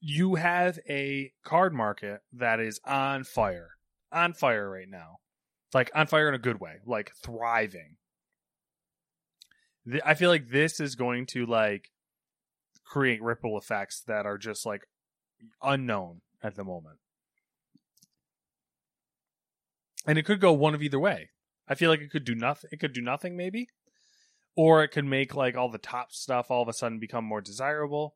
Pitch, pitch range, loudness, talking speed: 135 Hz, 115-155 Hz, -28 LUFS, 165 wpm